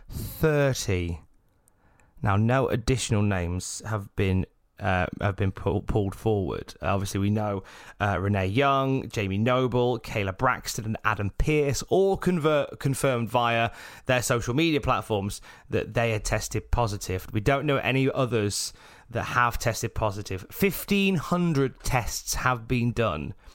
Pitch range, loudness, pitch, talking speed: 100-130 Hz, -26 LUFS, 110 Hz, 140 wpm